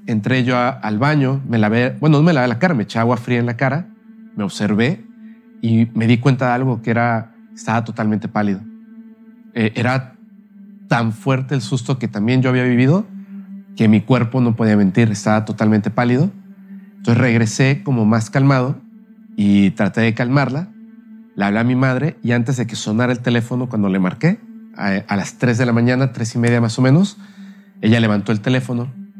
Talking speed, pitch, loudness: 195 wpm, 125 Hz, -17 LUFS